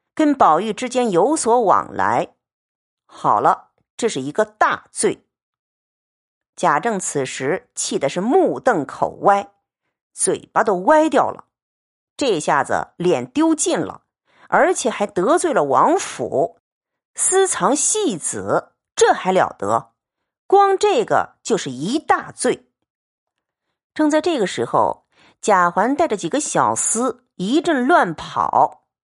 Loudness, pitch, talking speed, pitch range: -18 LUFS, 265 Hz, 170 characters per minute, 205-340 Hz